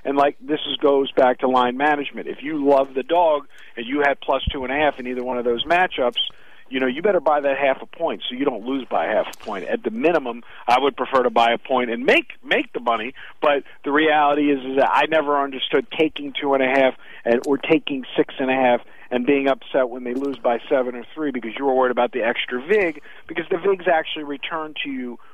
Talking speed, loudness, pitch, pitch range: 250 wpm, -21 LUFS, 140 Hz, 125-150 Hz